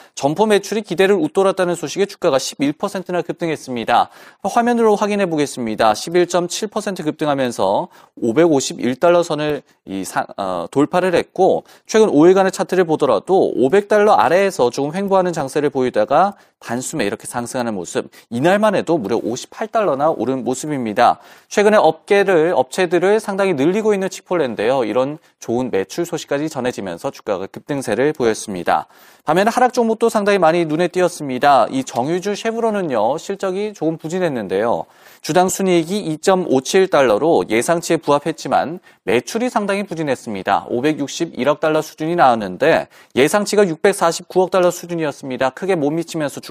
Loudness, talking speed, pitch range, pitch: -17 LUFS, 340 characters per minute, 145-200 Hz, 175 Hz